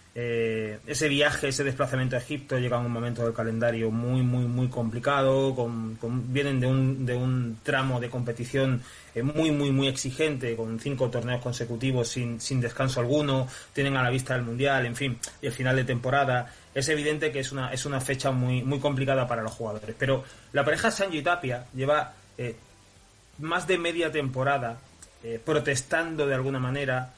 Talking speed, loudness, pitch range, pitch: 185 wpm, -27 LUFS, 120-140 Hz, 130 Hz